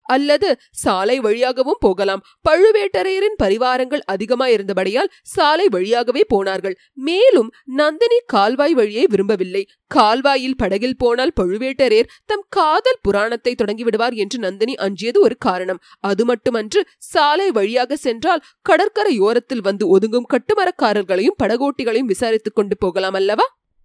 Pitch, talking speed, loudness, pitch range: 245 Hz, 105 wpm, -17 LUFS, 205-300 Hz